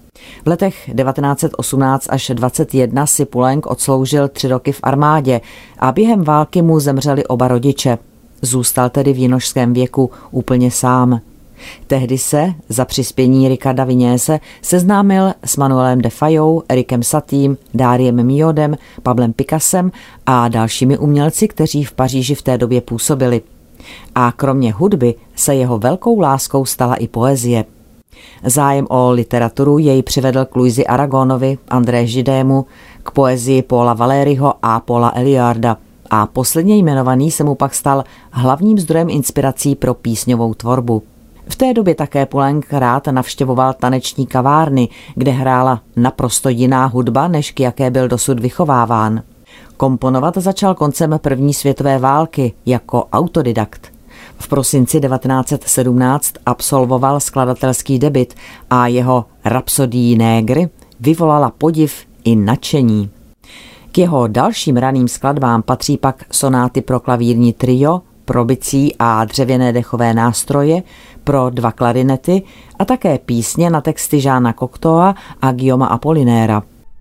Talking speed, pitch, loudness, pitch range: 130 wpm, 130 Hz, -14 LUFS, 125-145 Hz